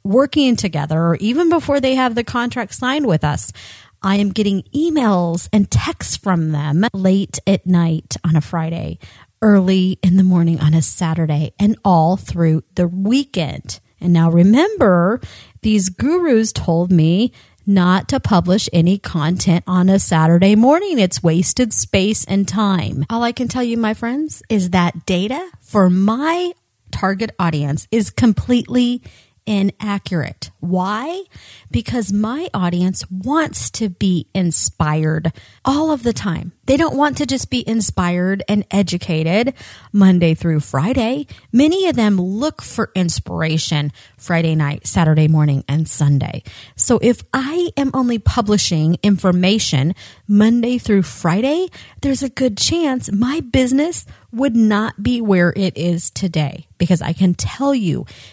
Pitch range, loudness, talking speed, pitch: 165-240 Hz, -16 LUFS, 145 wpm, 195 Hz